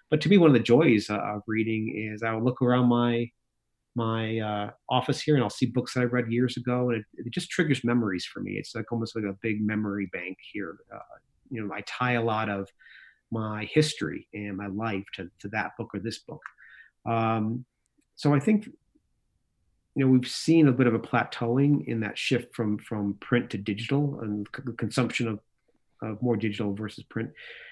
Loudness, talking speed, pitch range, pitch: -27 LUFS, 210 wpm, 105-125 Hz, 115 Hz